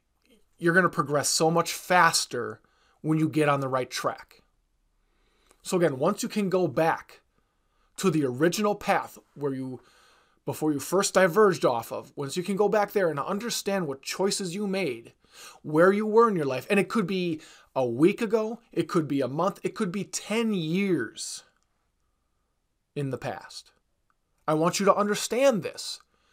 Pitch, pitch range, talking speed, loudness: 180 Hz, 150-205 Hz, 175 wpm, -26 LUFS